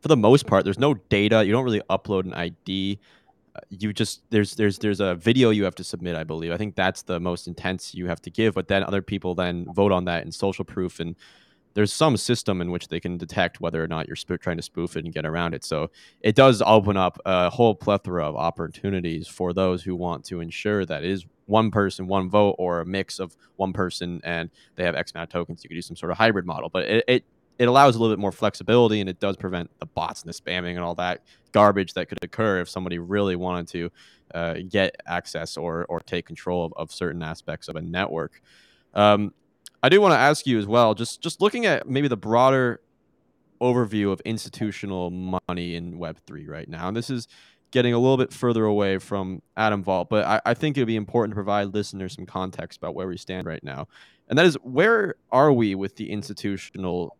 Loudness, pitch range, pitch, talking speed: -23 LUFS, 90-110 Hz, 95 Hz, 235 wpm